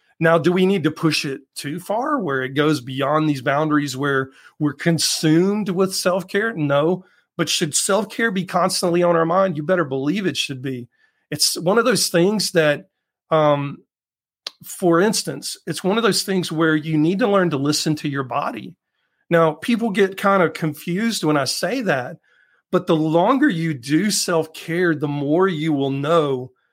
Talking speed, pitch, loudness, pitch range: 185 wpm, 165 Hz, -19 LUFS, 150-185 Hz